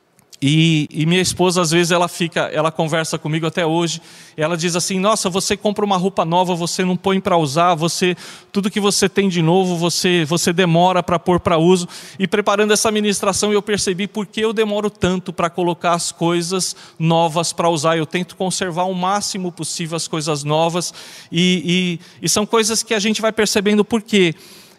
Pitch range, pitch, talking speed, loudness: 170-200 Hz, 180 Hz, 195 wpm, -17 LUFS